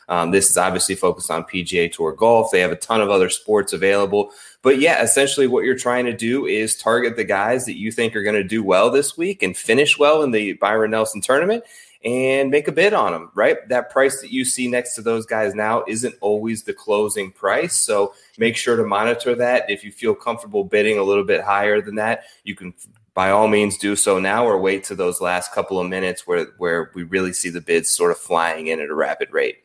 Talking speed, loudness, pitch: 235 wpm, -18 LUFS, 115 Hz